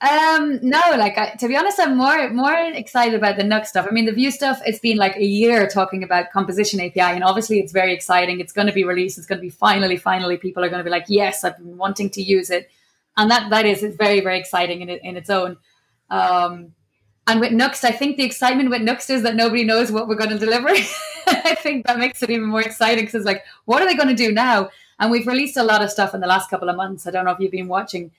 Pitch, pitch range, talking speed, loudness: 210 Hz, 185-245 Hz, 270 wpm, -18 LUFS